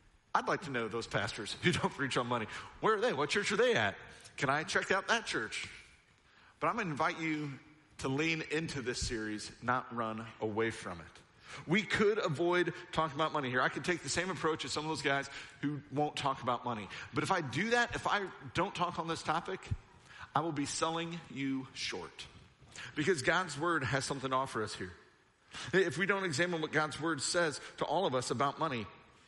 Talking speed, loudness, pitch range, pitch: 215 wpm, -34 LUFS, 130-170 Hz, 150 Hz